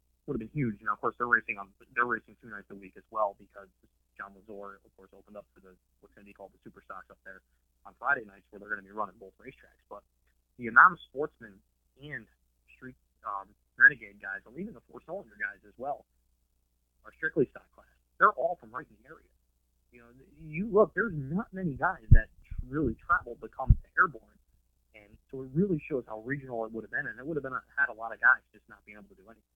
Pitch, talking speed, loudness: 100 Hz, 240 wpm, -29 LUFS